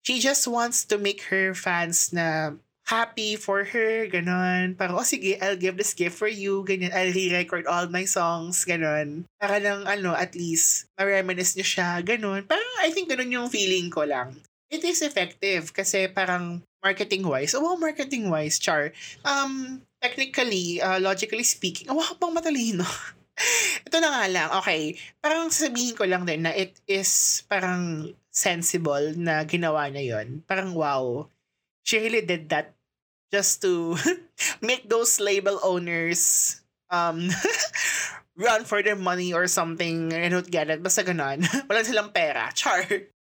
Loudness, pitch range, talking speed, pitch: -24 LUFS, 175-220 Hz, 155 wpm, 190 Hz